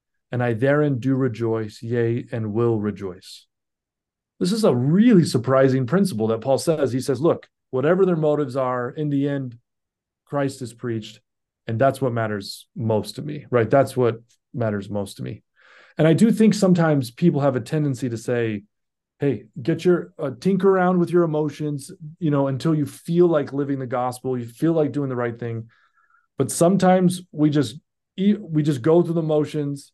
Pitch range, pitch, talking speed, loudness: 120-160 Hz, 135 Hz, 180 wpm, -21 LUFS